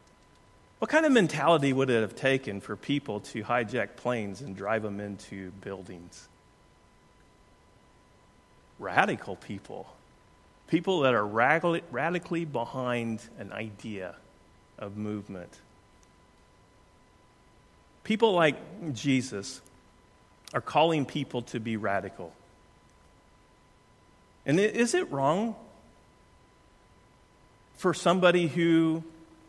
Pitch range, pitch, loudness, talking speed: 100-160 Hz, 115 Hz, -28 LUFS, 90 wpm